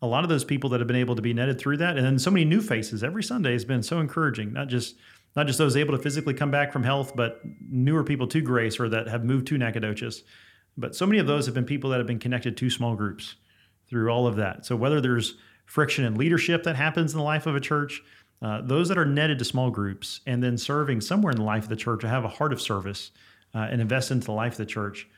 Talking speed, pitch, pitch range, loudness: 275 wpm, 125 Hz, 115-145 Hz, -26 LUFS